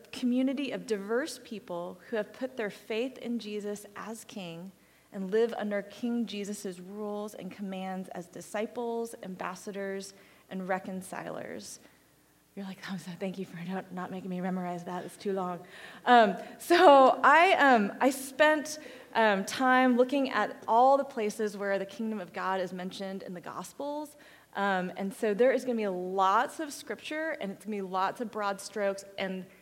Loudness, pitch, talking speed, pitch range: -29 LUFS, 205 Hz, 175 wpm, 190-240 Hz